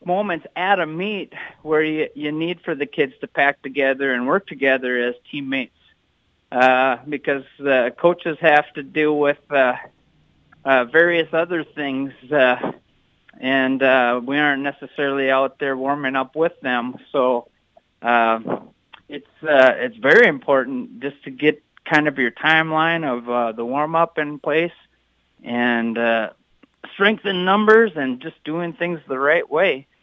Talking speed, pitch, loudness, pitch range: 150 wpm, 140 Hz, -19 LUFS, 130-160 Hz